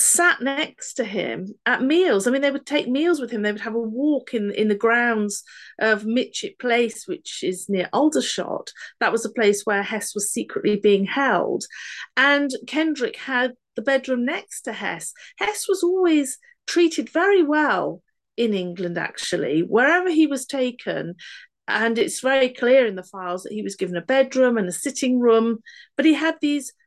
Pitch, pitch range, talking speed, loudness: 255 Hz, 215-300 Hz, 185 wpm, -21 LUFS